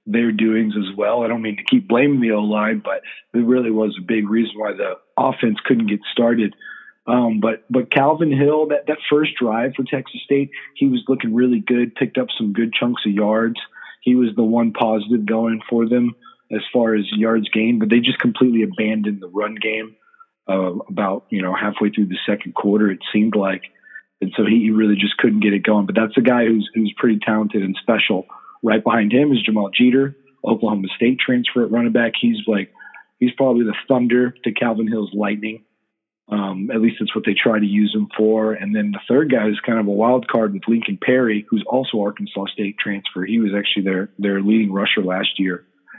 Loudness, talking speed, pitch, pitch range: -18 LUFS, 215 wpm, 110 Hz, 105-120 Hz